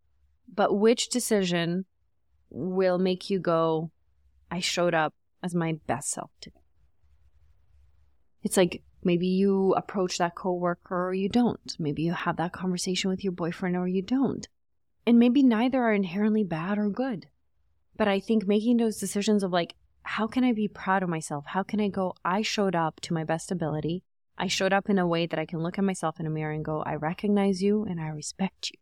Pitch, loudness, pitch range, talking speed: 180 Hz, -27 LUFS, 160-200 Hz, 195 wpm